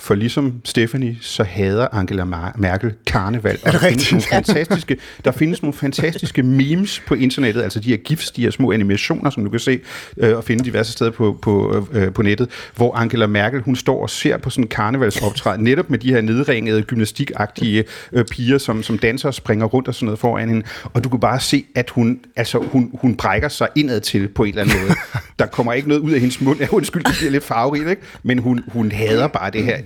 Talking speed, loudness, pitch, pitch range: 220 wpm, -18 LUFS, 120 Hz, 110-135 Hz